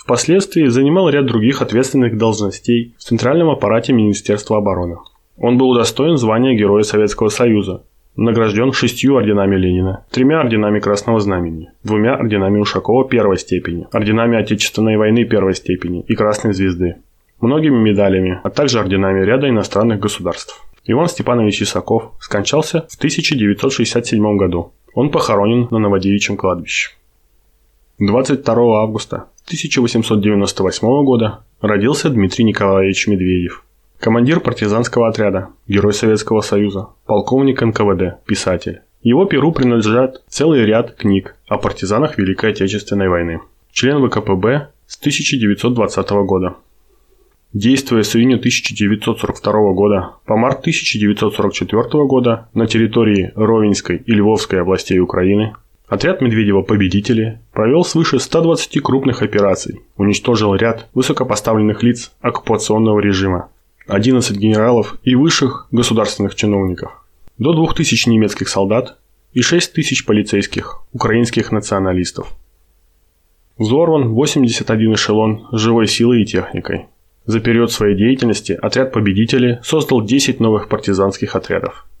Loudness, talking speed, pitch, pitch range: -15 LUFS, 115 wpm, 110 Hz, 100-125 Hz